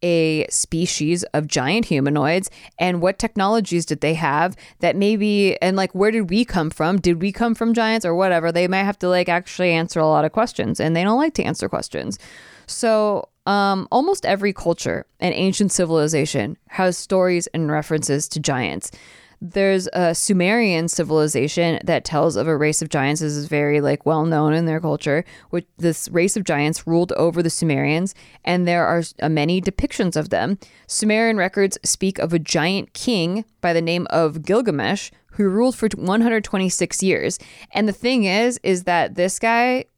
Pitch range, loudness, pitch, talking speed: 160-200 Hz, -20 LUFS, 175 Hz, 180 wpm